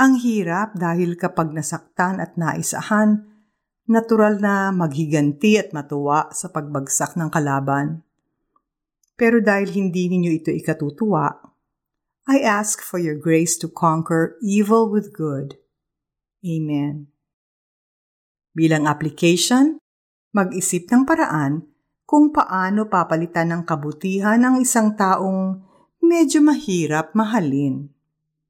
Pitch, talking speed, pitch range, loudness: 175 Hz, 105 wpm, 155-210 Hz, -19 LUFS